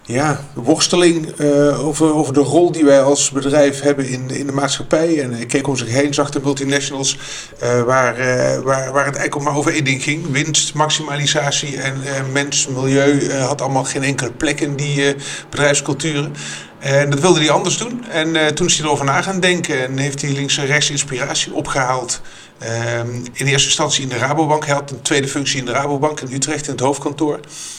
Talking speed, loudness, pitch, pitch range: 210 wpm, -16 LUFS, 140 Hz, 135-150 Hz